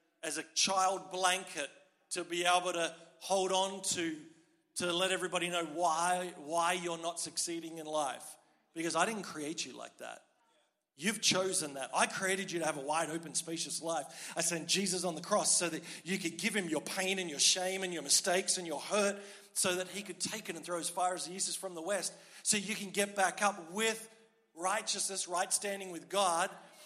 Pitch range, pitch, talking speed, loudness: 170-195 Hz, 185 Hz, 210 wpm, -34 LUFS